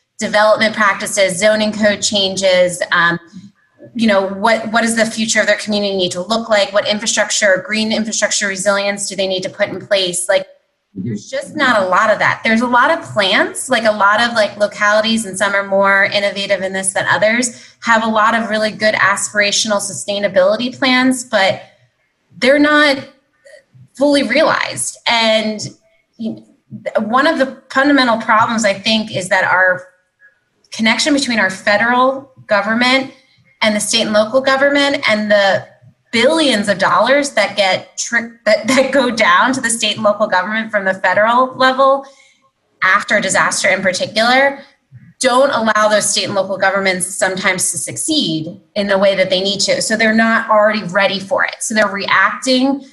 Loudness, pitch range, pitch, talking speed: -14 LUFS, 200-255 Hz, 215 Hz, 170 wpm